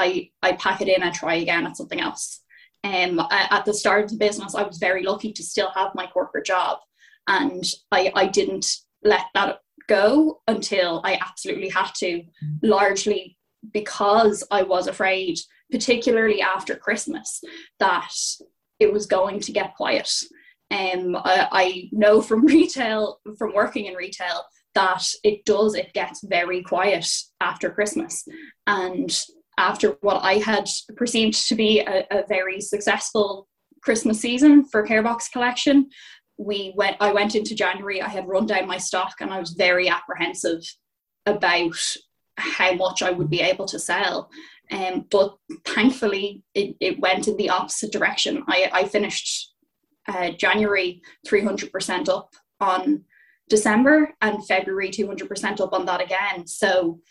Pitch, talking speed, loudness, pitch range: 200 Hz, 160 wpm, -22 LUFS, 185-220 Hz